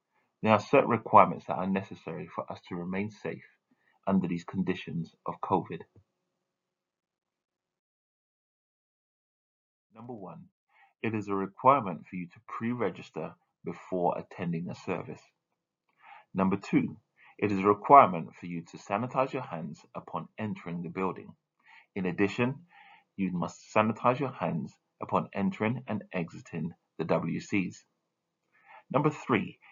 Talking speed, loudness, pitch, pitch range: 125 wpm, -30 LUFS, 100 Hz, 90-110 Hz